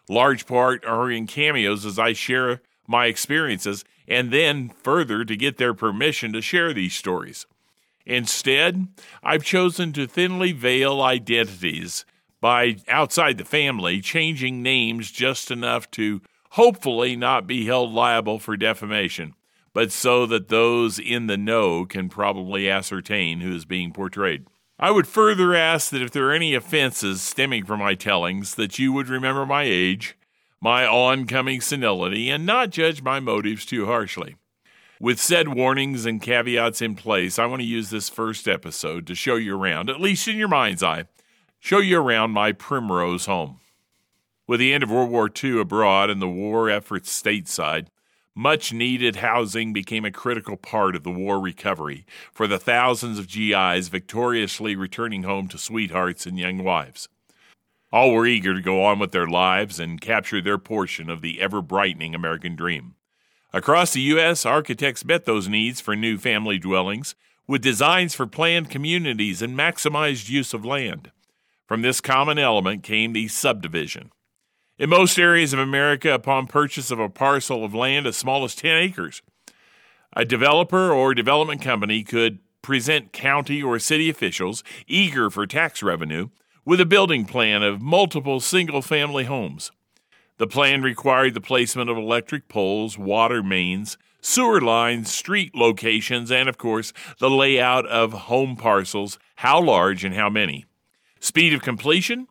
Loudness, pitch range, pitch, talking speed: -21 LUFS, 105-140 Hz, 120 Hz, 160 wpm